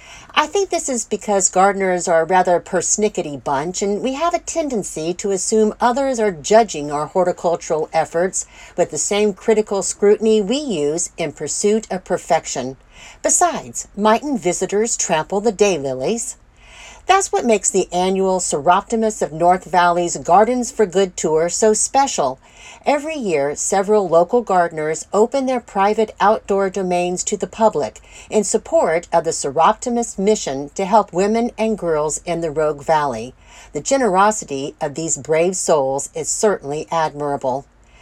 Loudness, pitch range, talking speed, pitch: -18 LUFS, 165-220 Hz, 150 wpm, 195 Hz